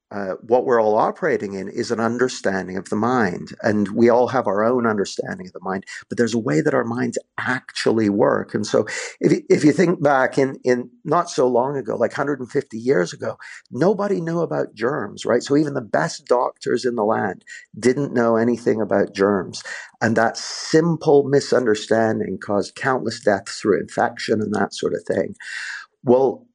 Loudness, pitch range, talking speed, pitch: -20 LUFS, 110-150 Hz, 190 wpm, 125 Hz